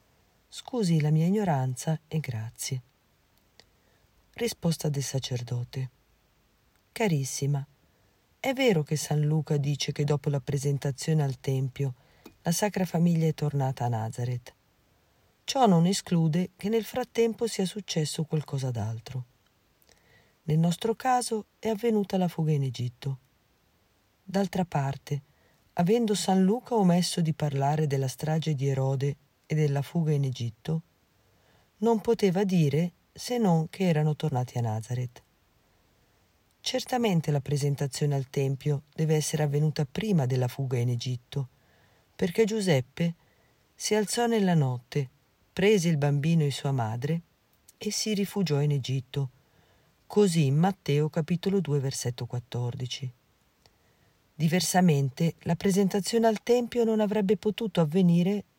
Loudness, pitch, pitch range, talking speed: -28 LUFS, 155 Hz, 135-190 Hz, 125 wpm